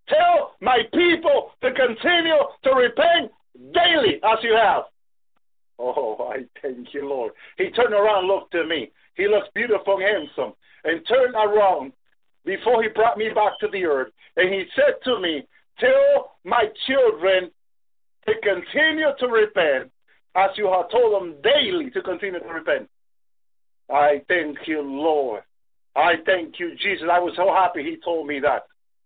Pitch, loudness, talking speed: 210 Hz, -21 LUFS, 160 wpm